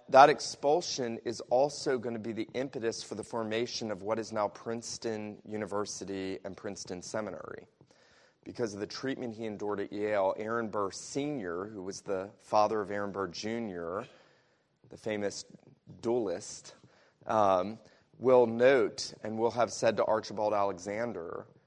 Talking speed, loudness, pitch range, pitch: 145 wpm, -32 LUFS, 100-115 Hz, 110 Hz